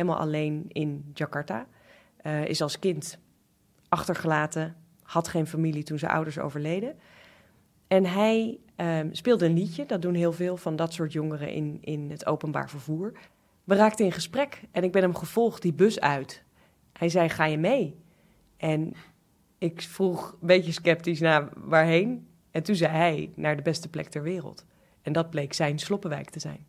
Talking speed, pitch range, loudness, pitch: 175 wpm, 155-180 Hz, -27 LUFS, 165 Hz